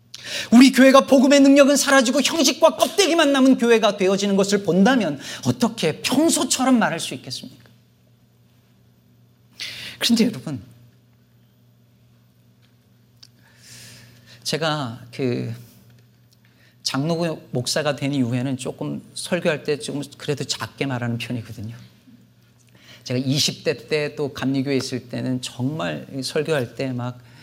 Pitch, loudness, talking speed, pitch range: 135 Hz, -20 LUFS, 245 characters per minute, 120-200 Hz